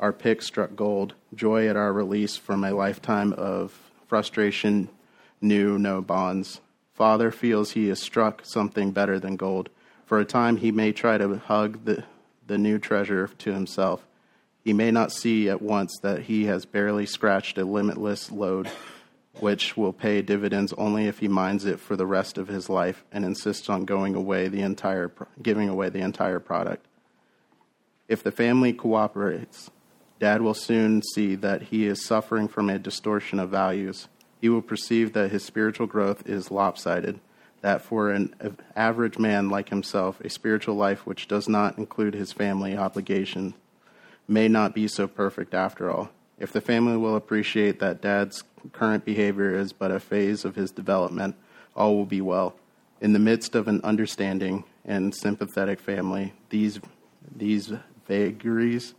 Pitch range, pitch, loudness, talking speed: 95-110 Hz, 100 Hz, -25 LUFS, 165 wpm